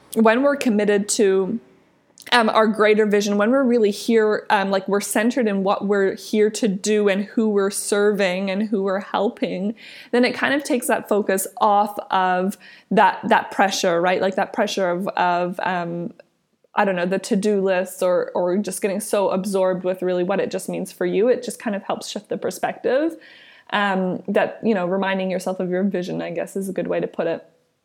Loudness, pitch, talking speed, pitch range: -20 LUFS, 205 Hz, 205 wpm, 190-220 Hz